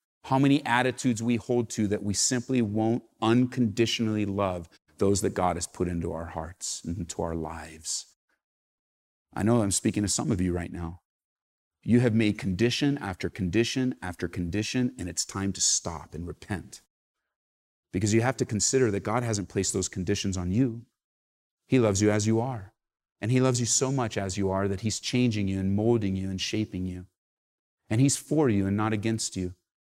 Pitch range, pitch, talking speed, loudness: 90-120 Hz, 105 Hz, 190 wpm, -27 LUFS